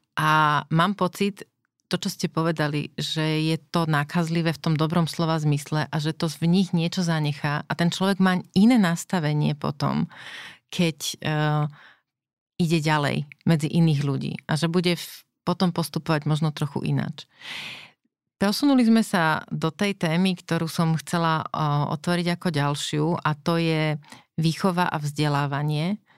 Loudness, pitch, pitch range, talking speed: -24 LUFS, 165 Hz, 150-175 Hz, 150 wpm